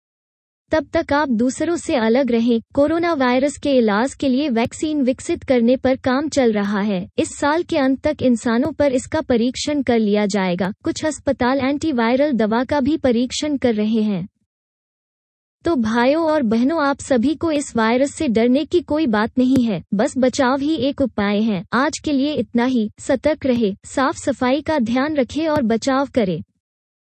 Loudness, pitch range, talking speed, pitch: -19 LUFS, 230-295 Hz, 175 wpm, 265 Hz